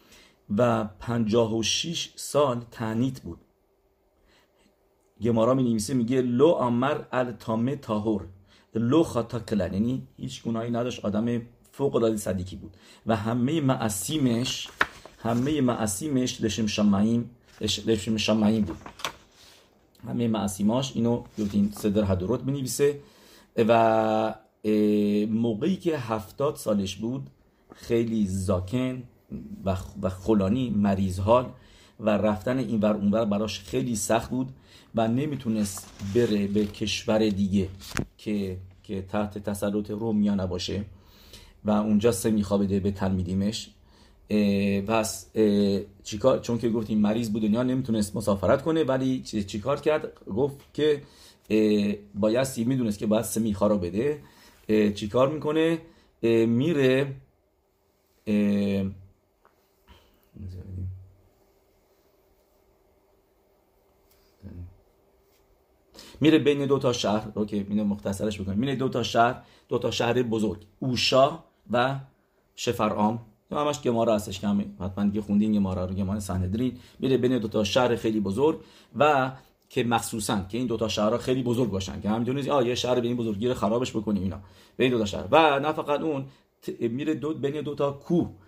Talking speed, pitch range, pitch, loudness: 130 wpm, 100-125 Hz, 110 Hz, -26 LUFS